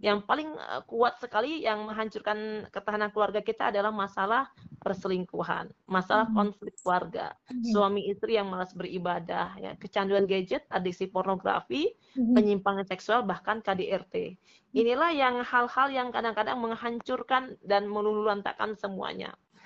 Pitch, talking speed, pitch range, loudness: 210 Hz, 115 wpm, 195-230 Hz, -29 LUFS